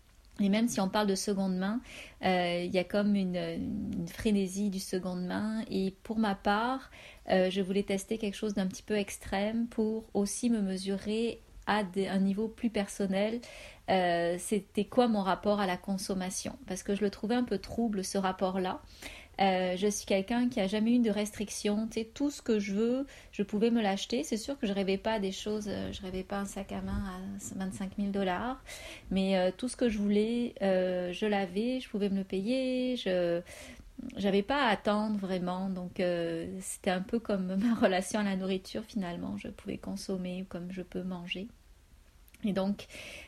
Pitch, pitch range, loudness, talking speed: 200 Hz, 190-220 Hz, -32 LUFS, 200 wpm